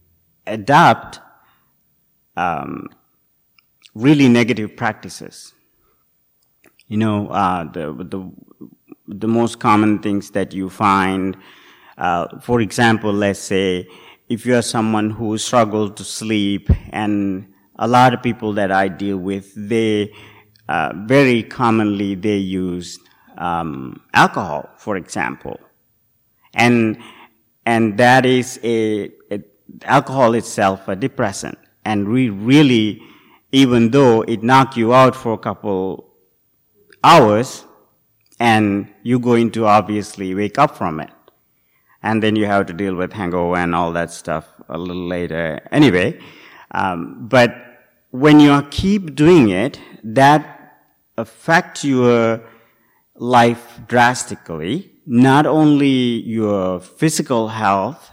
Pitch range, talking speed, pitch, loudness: 100-120 Hz, 120 wpm, 110 Hz, -16 LUFS